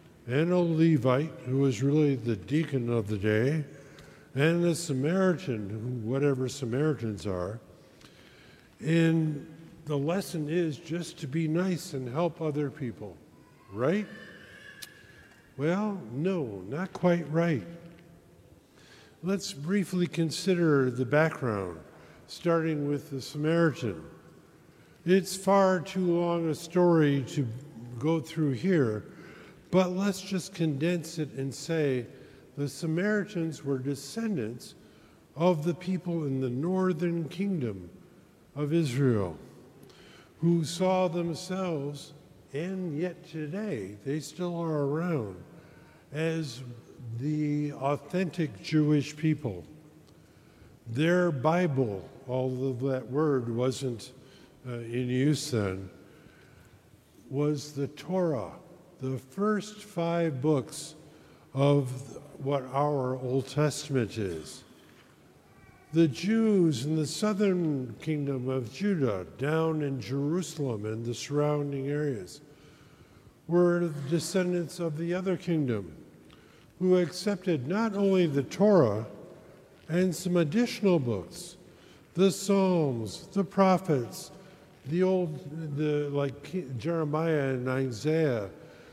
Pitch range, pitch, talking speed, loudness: 135-175 Hz, 155 Hz, 105 wpm, -29 LUFS